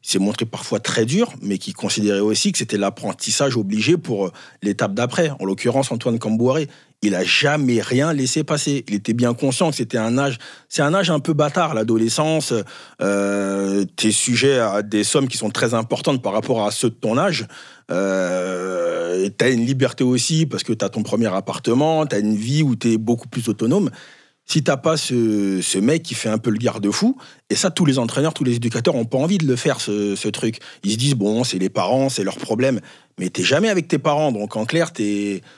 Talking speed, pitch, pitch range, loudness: 225 wpm, 120 Hz, 105-145 Hz, -19 LUFS